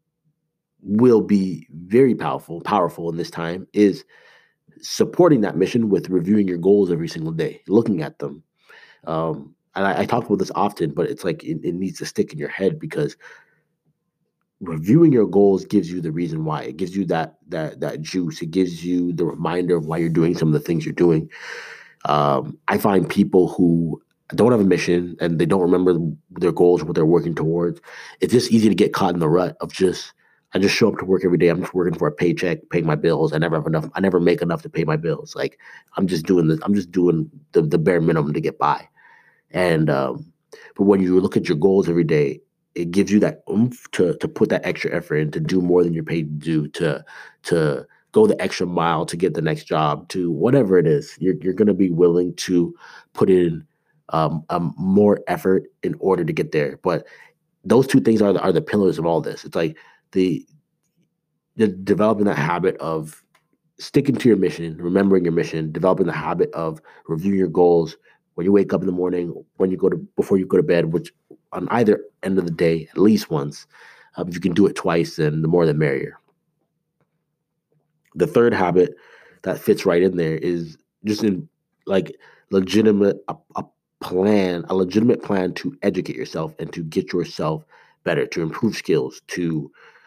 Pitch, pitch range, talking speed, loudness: 90 Hz, 85-100 Hz, 210 wpm, -20 LUFS